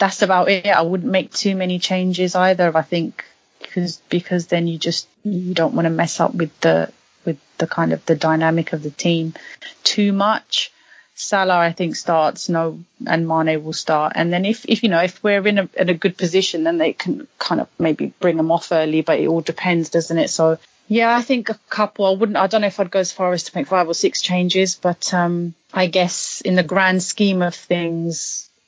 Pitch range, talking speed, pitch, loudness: 165-195 Hz, 225 wpm, 180 Hz, -19 LUFS